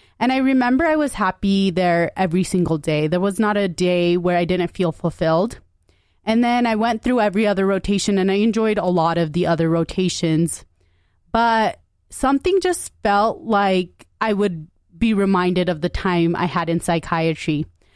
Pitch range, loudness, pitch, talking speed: 170-210 Hz, -19 LUFS, 180 Hz, 175 wpm